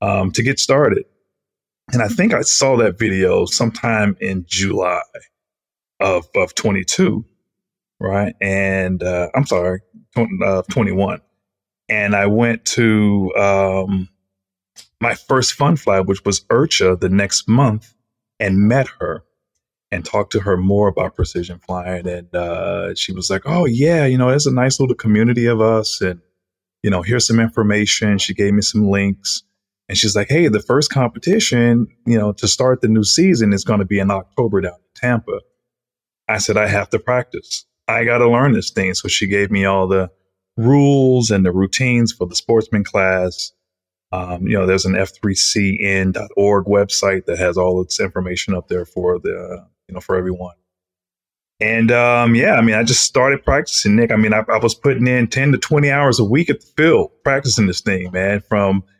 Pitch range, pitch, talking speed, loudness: 95-115 Hz, 100 Hz, 180 wpm, -16 LUFS